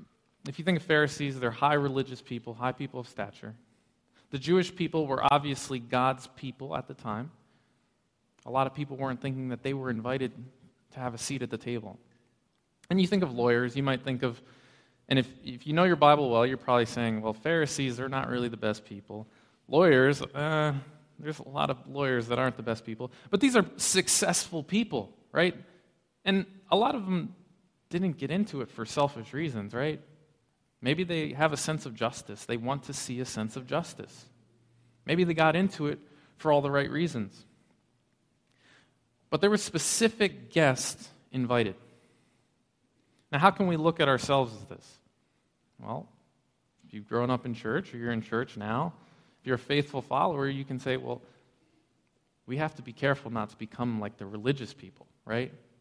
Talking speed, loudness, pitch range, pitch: 185 wpm, -29 LUFS, 120-155 Hz, 135 Hz